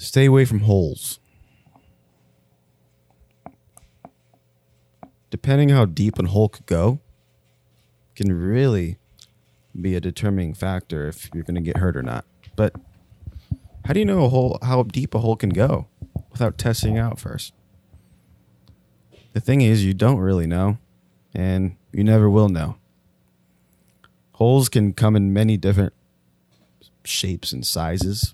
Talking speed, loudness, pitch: 140 wpm, -20 LUFS, 95 Hz